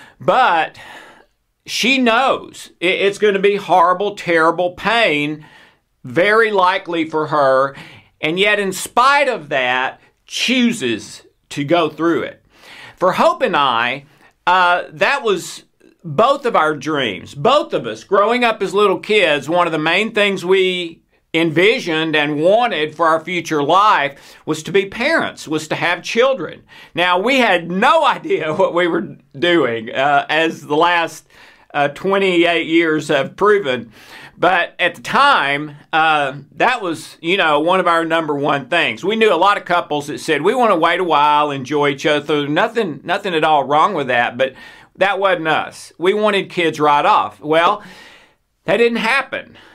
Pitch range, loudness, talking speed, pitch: 155-200 Hz, -16 LUFS, 165 wpm, 170 Hz